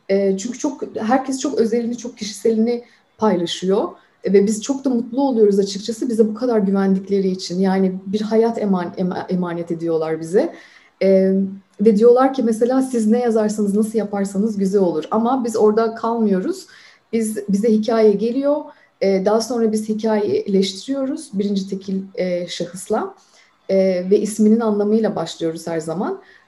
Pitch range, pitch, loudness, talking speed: 195-235 Hz, 215 Hz, -19 LUFS, 135 wpm